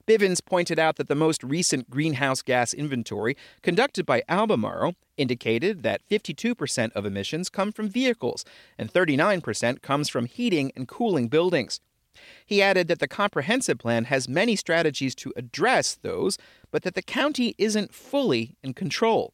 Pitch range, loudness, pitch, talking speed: 130-205 Hz, -25 LUFS, 155 Hz, 150 wpm